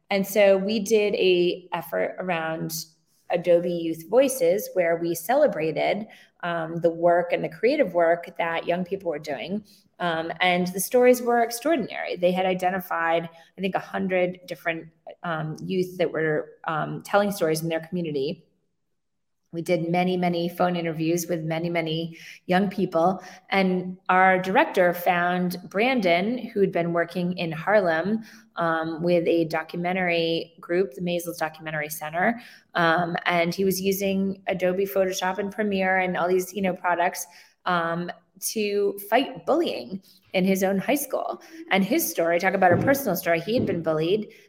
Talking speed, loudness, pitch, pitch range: 155 wpm, -24 LUFS, 180 Hz, 170-195 Hz